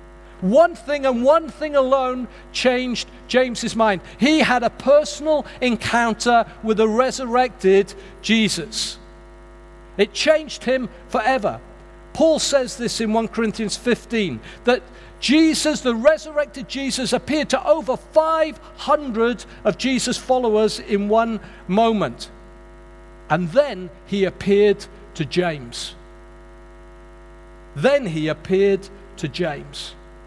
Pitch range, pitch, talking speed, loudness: 195-265 Hz, 230 Hz, 110 wpm, -20 LUFS